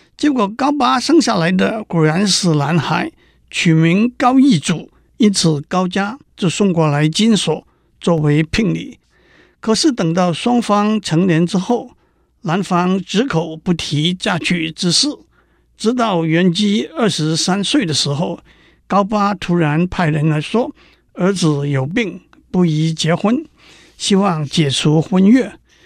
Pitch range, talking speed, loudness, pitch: 160-215 Hz, 195 characters per minute, -16 LUFS, 180 Hz